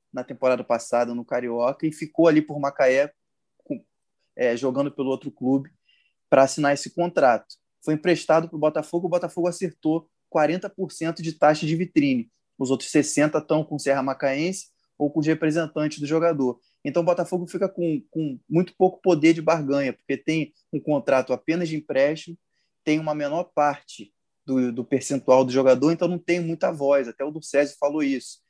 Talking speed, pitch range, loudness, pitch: 180 wpm, 140-170 Hz, -23 LUFS, 155 Hz